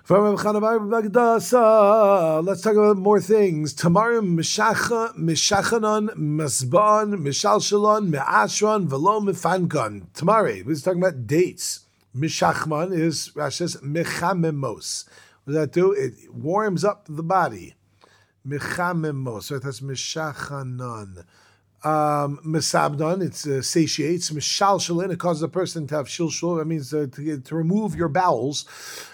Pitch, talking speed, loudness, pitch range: 165 Hz, 125 wpm, -21 LUFS, 145-200 Hz